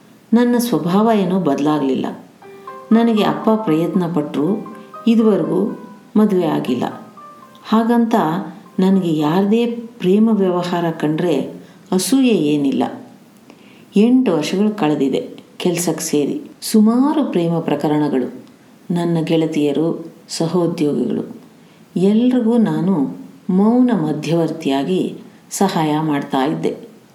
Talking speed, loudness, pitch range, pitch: 80 wpm, -17 LUFS, 160-230 Hz, 195 Hz